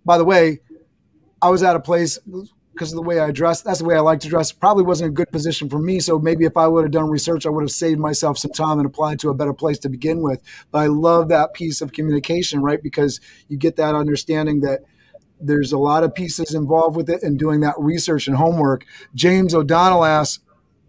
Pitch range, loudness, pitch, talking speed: 150-170 Hz, -18 LUFS, 160 Hz, 240 wpm